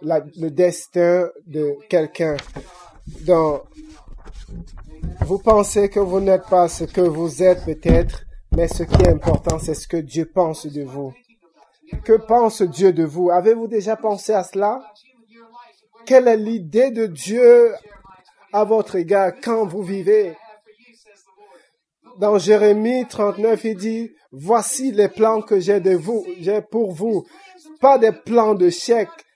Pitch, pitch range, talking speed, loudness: 205 Hz, 175-225 Hz, 140 wpm, -18 LUFS